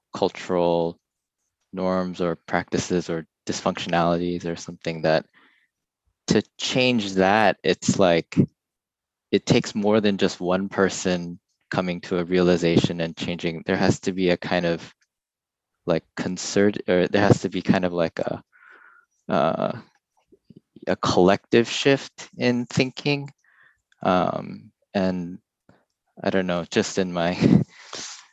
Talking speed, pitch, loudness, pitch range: 125 wpm, 90 Hz, -23 LUFS, 85-105 Hz